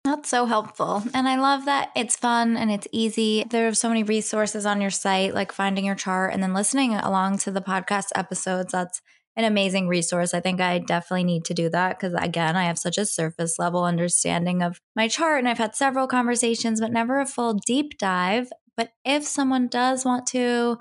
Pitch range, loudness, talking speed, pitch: 185-240 Hz, -23 LUFS, 210 wpm, 215 Hz